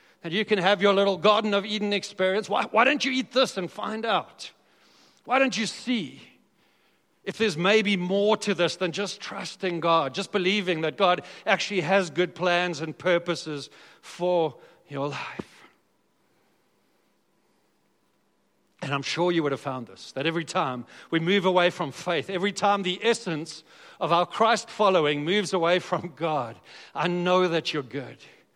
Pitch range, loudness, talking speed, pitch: 165-205 Hz, -25 LUFS, 165 wpm, 185 Hz